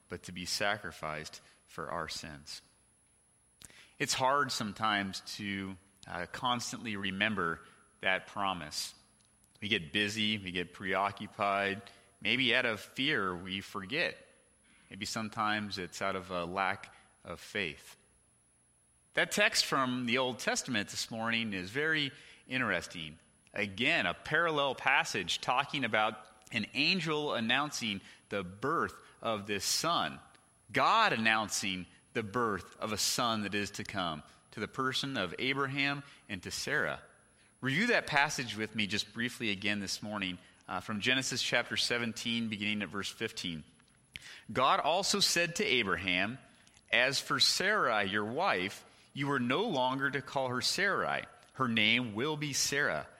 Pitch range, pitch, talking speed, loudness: 95-130 Hz, 105 Hz, 140 wpm, -32 LUFS